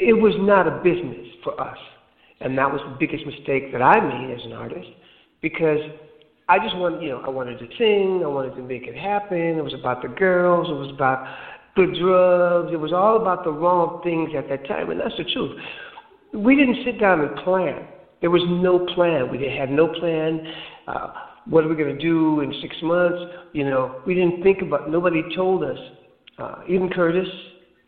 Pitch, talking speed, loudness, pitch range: 170 Hz, 205 wpm, -21 LUFS, 145-185 Hz